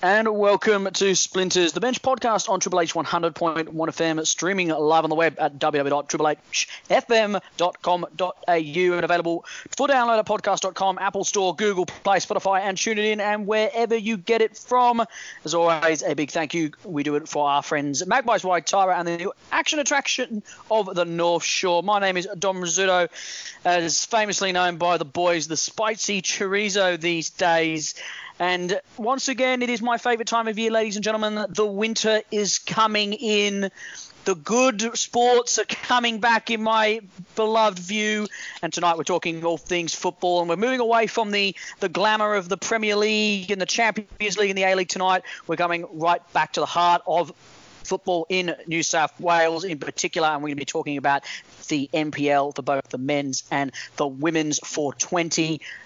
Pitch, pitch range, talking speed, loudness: 185 Hz, 165-215 Hz, 180 wpm, -22 LUFS